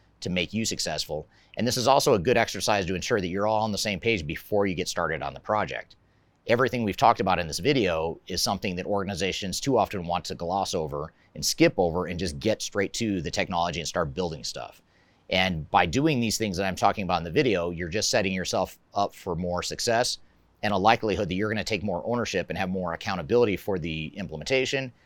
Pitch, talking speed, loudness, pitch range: 95 Hz, 225 wpm, -26 LUFS, 90-110 Hz